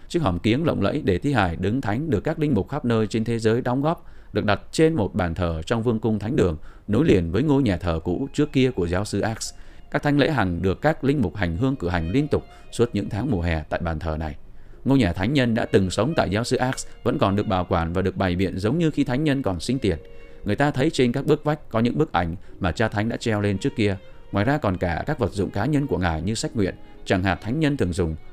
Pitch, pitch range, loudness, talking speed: 105 Hz, 90-135 Hz, -23 LUFS, 285 wpm